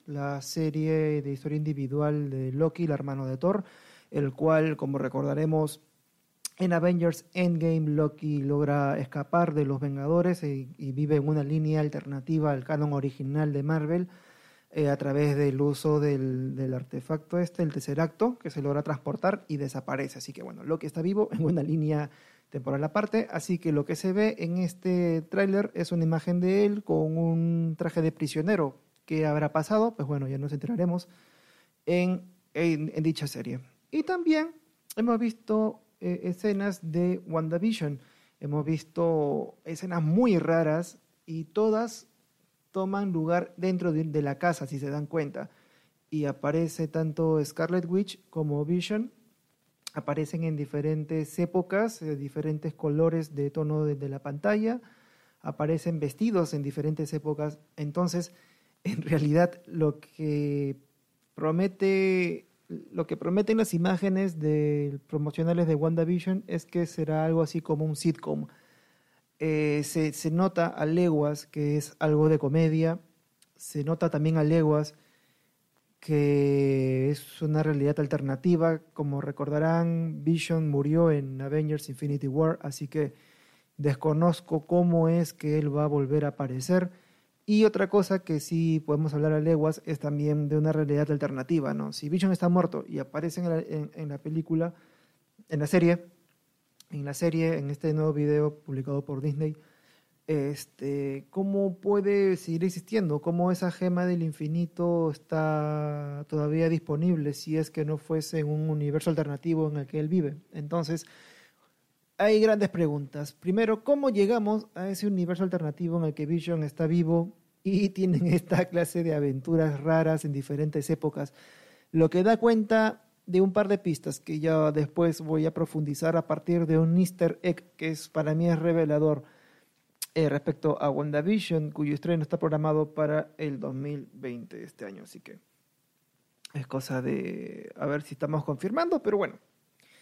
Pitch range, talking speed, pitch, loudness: 150-175 Hz, 155 wpm, 160 Hz, -28 LUFS